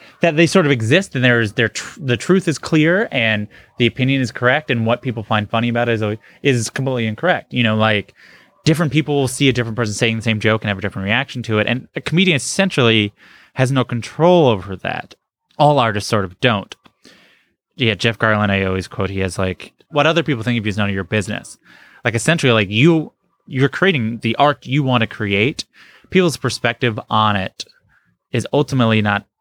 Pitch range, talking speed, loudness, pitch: 110-145 Hz, 210 wpm, -17 LUFS, 120 Hz